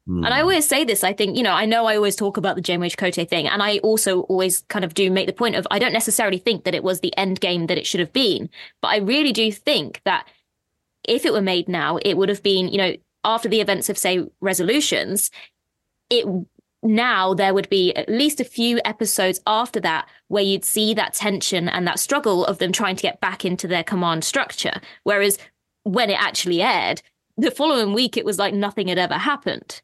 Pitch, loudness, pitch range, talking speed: 200 Hz, -20 LUFS, 185-220 Hz, 230 wpm